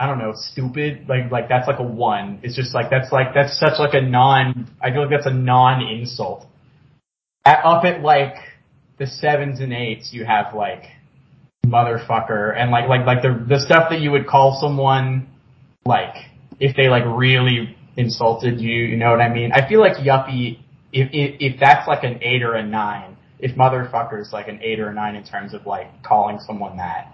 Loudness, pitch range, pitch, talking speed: -18 LUFS, 120-140 Hz, 130 Hz, 205 wpm